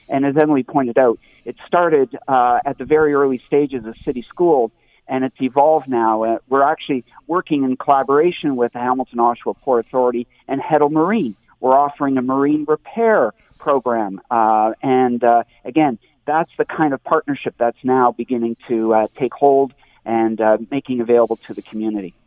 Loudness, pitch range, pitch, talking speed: -17 LUFS, 120-145 Hz, 130 Hz, 170 wpm